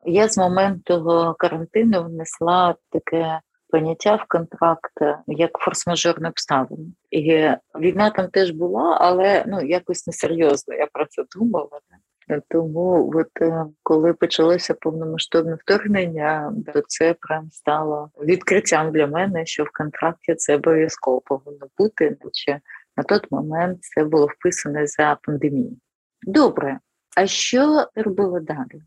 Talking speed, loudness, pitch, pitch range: 125 wpm, -20 LUFS, 165 Hz, 155-180 Hz